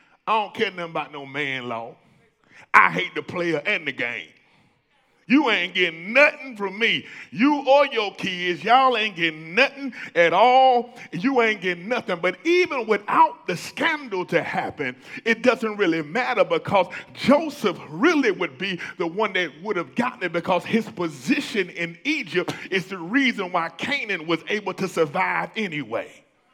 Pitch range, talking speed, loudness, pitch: 175-255 Hz, 165 wpm, -22 LUFS, 200 Hz